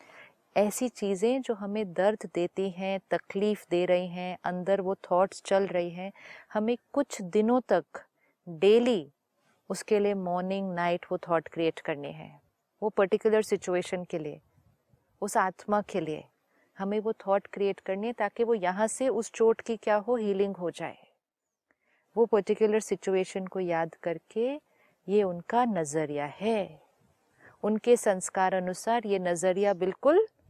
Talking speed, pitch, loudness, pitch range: 145 wpm, 195 Hz, -29 LUFS, 180-220 Hz